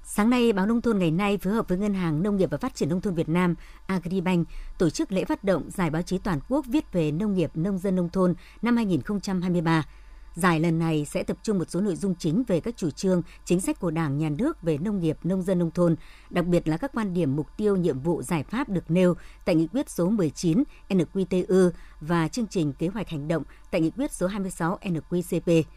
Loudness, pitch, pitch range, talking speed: -26 LUFS, 180 Hz, 165-195 Hz, 240 wpm